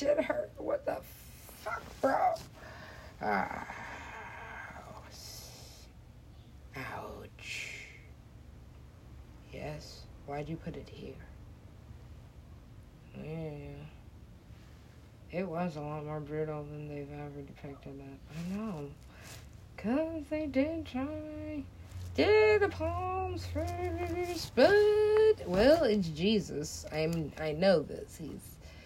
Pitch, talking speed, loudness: 155 Hz, 95 wpm, -33 LUFS